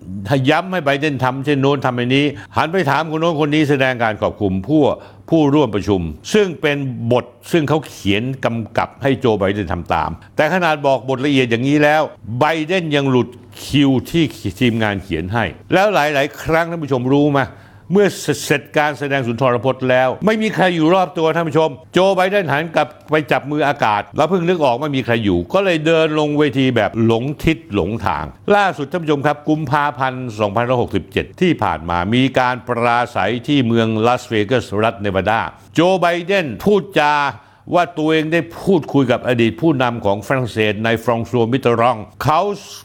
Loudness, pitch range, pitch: -17 LUFS, 115-155 Hz, 135 Hz